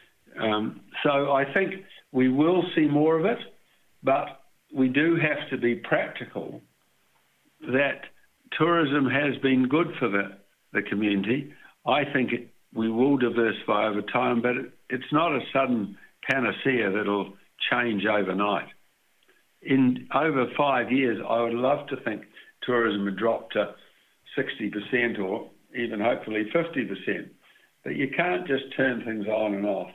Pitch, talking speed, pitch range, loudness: 120 Hz, 140 wpm, 105-140 Hz, -26 LUFS